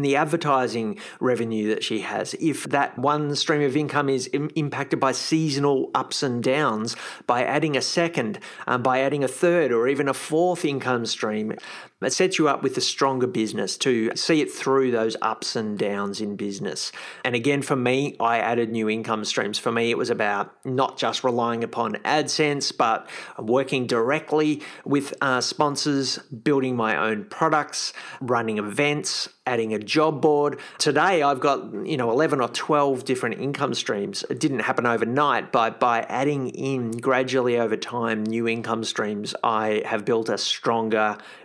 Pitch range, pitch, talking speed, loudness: 115-145 Hz, 130 Hz, 170 wpm, -23 LUFS